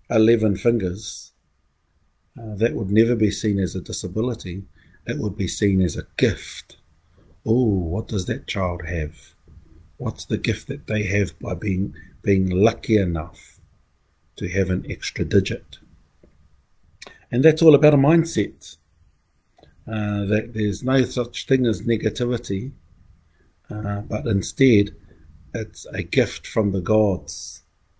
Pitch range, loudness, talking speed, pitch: 85-110 Hz, -22 LUFS, 135 wpm, 100 Hz